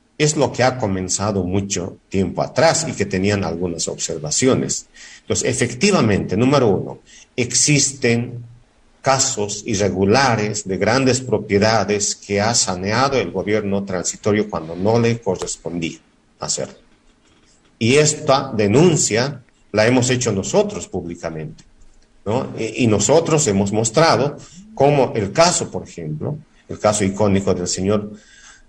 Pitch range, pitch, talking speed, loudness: 95-130 Hz, 105 Hz, 120 wpm, -18 LUFS